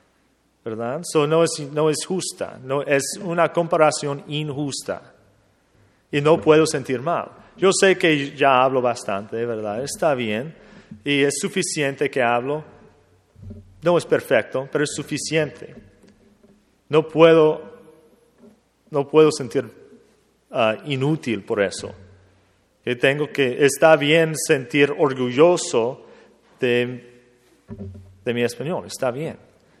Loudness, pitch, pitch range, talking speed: -20 LUFS, 145 Hz, 120-160 Hz, 120 wpm